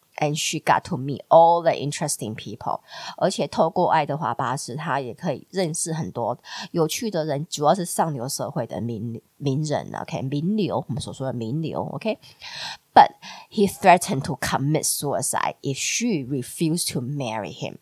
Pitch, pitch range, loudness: 155 Hz, 140-170 Hz, -23 LUFS